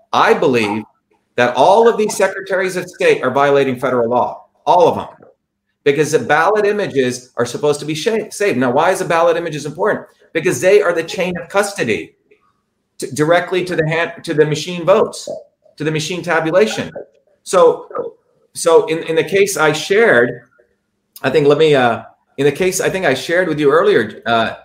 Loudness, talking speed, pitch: -15 LUFS, 185 wpm, 185 Hz